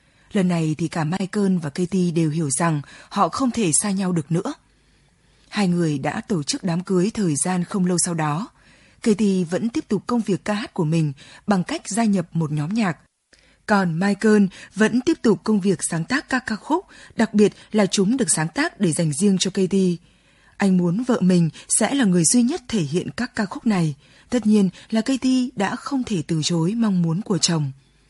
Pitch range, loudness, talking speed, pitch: 170-220 Hz, -21 LUFS, 210 wpm, 195 Hz